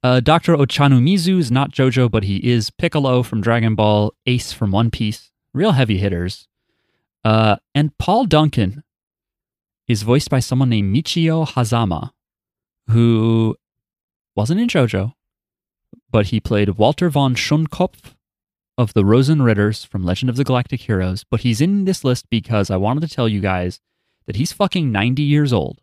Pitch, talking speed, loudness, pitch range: 120 Hz, 160 wpm, -17 LUFS, 105-140 Hz